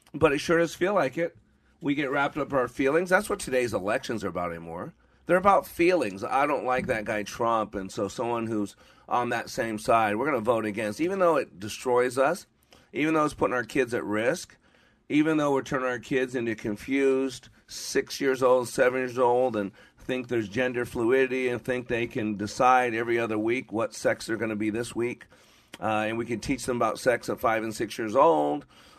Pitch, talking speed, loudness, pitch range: 125 Hz, 215 wpm, -27 LUFS, 110-135 Hz